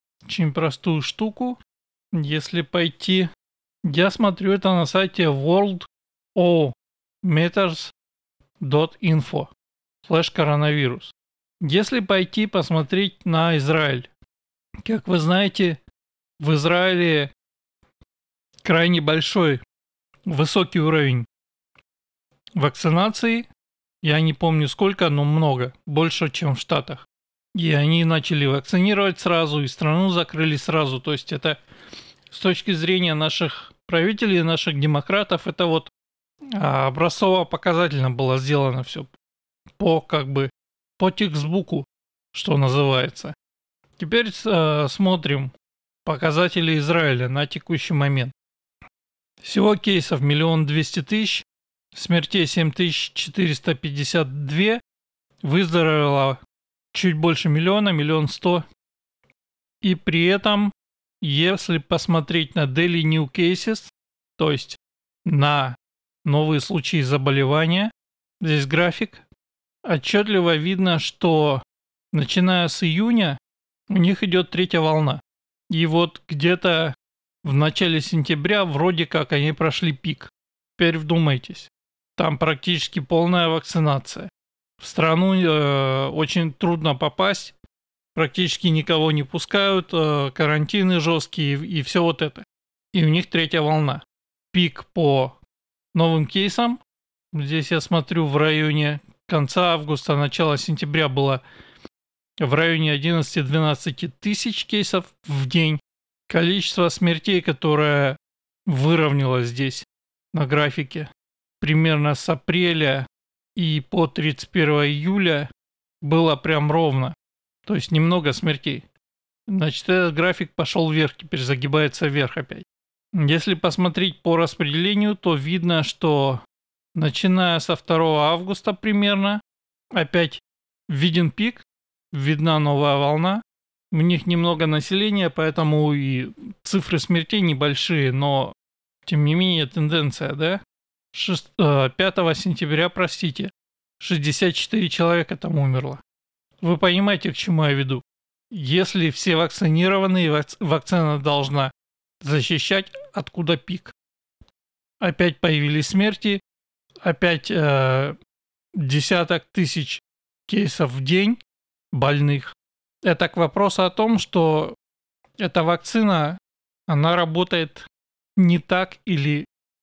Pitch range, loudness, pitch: 145-180 Hz, -21 LUFS, 160 Hz